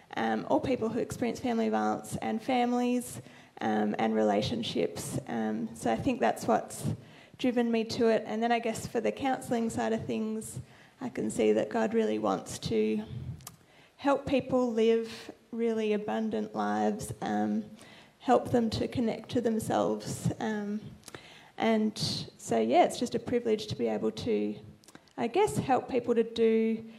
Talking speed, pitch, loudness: 160 wpm, 220 Hz, -30 LUFS